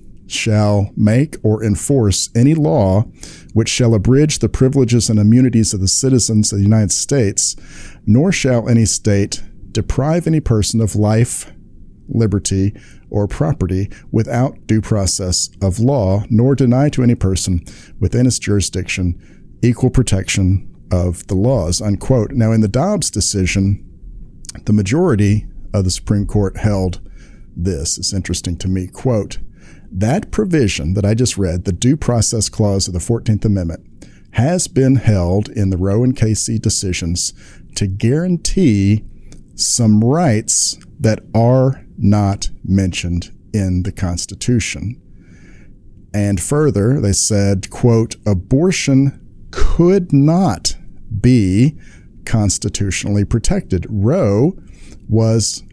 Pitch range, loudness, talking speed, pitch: 95-120 Hz, -15 LUFS, 125 wpm, 105 Hz